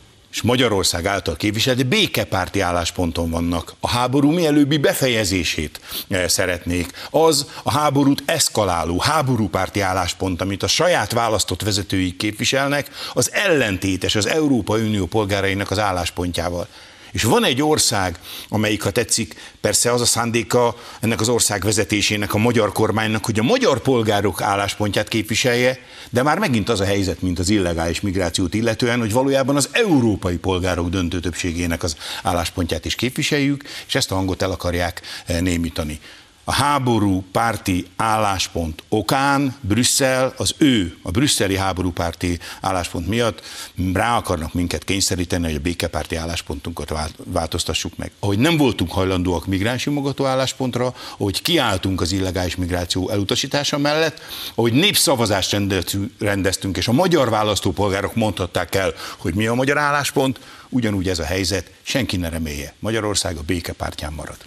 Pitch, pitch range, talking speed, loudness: 100 Hz, 90-120 Hz, 135 wpm, -19 LUFS